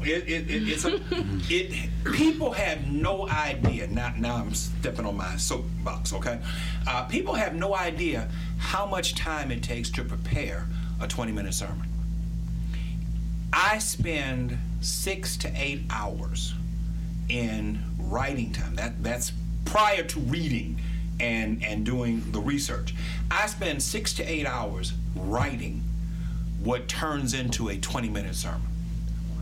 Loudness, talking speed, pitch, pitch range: -29 LUFS, 135 wpm, 155 Hz, 120-170 Hz